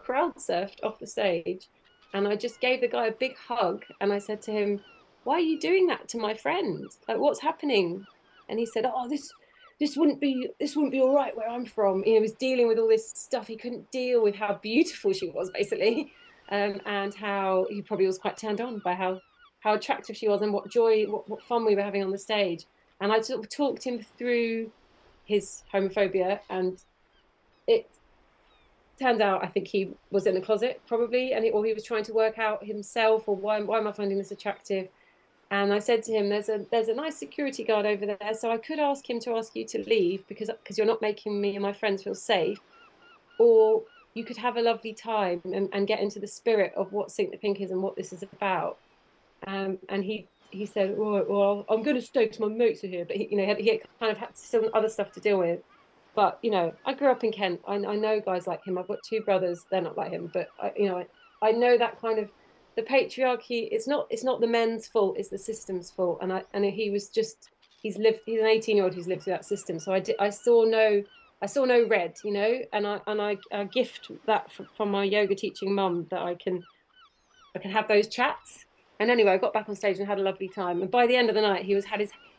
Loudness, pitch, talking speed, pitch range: -28 LUFS, 215 Hz, 245 wpm, 200-235 Hz